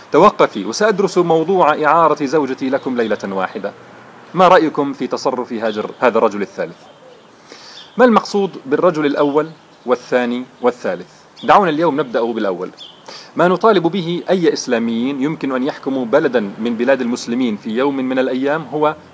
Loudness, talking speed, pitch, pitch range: -16 LUFS, 135 wpm, 145 Hz, 130-175 Hz